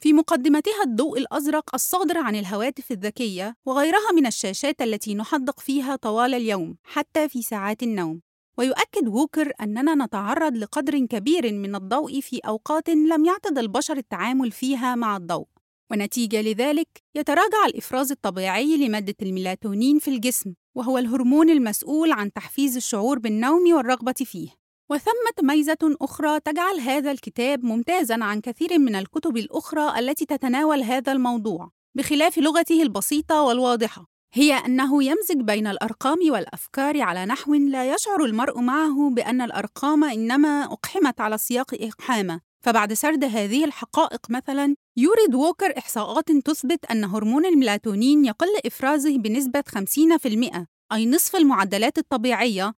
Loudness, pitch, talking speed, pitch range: -22 LUFS, 265 Hz, 130 wpm, 225-300 Hz